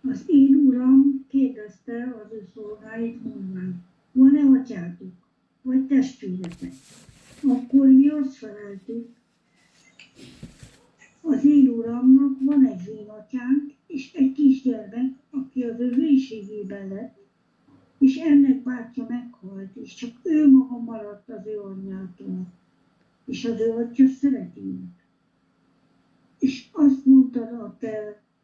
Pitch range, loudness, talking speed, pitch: 205-270 Hz, -20 LUFS, 110 wpm, 240 Hz